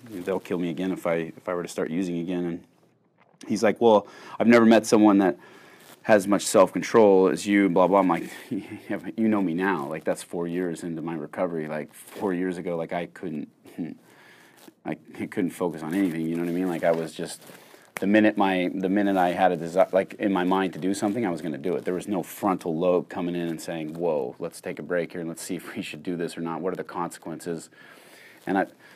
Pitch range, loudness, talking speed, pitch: 85-95 Hz, -25 LUFS, 245 wpm, 90 Hz